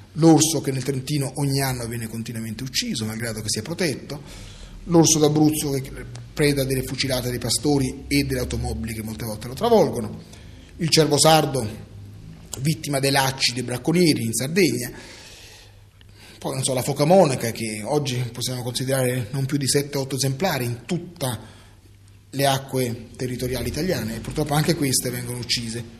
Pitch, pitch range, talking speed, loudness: 130 Hz, 115-145 Hz, 150 wpm, -22 LUFS